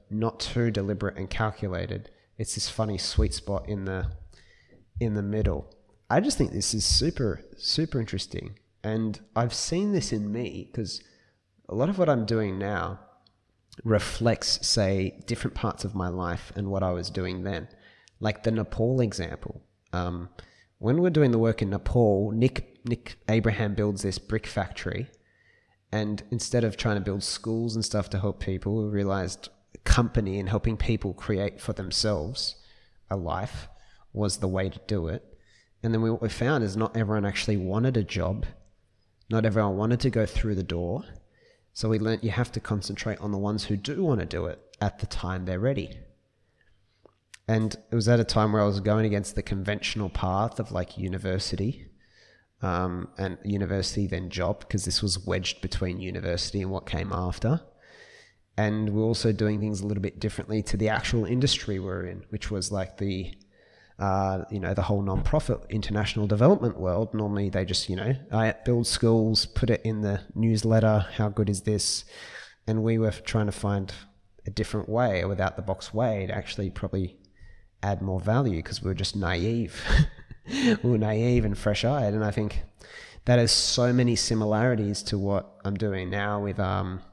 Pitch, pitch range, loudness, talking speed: 105 Hz, 95-110 Hz, -27 LUFS, 180 wpm